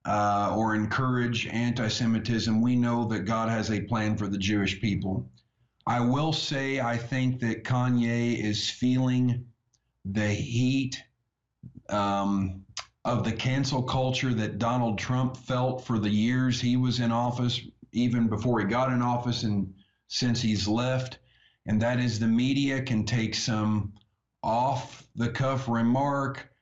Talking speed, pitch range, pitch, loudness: 145 wpm, 110-125 Hz, 120 Hz, -27 LUFS